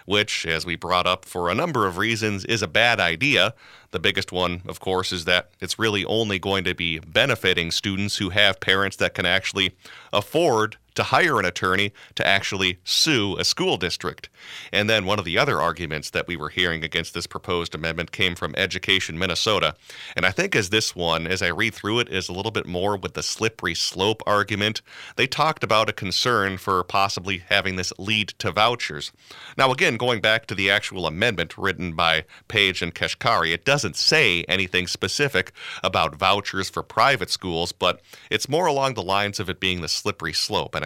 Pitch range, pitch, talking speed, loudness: 90-105 Hz, 95 Hz, 195 wpm, -22 LUFS